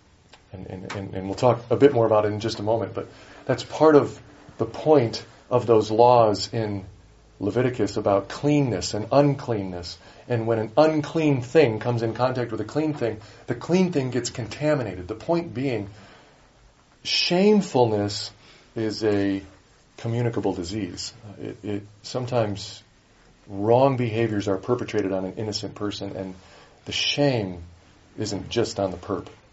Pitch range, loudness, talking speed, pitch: 100-125 Hz, -23 LUFS, 150 wpm, 110 Hz